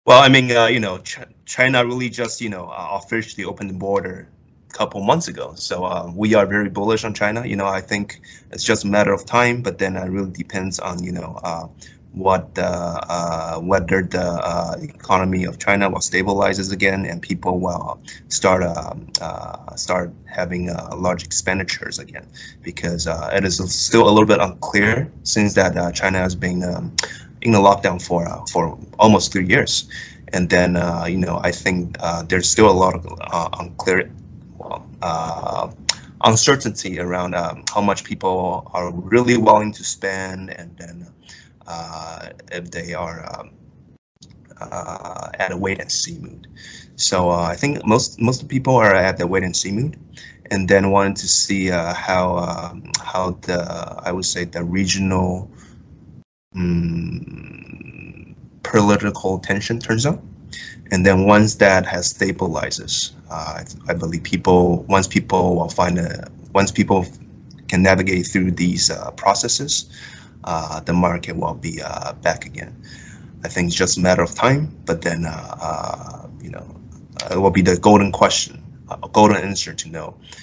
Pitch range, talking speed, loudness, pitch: 90-105 Hz, 170 wpm, -18 LUFS, 95 Hz